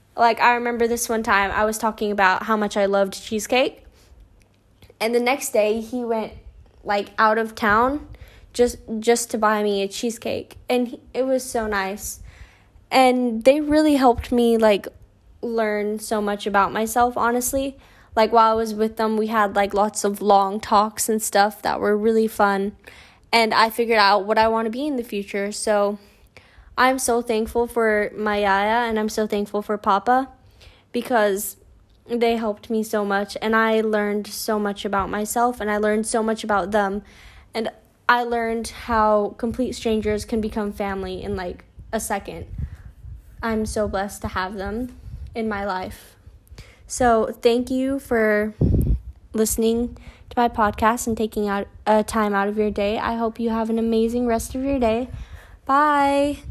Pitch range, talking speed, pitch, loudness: 205-235 Hz, 175 wpm, 220 Hz, -21 LUFS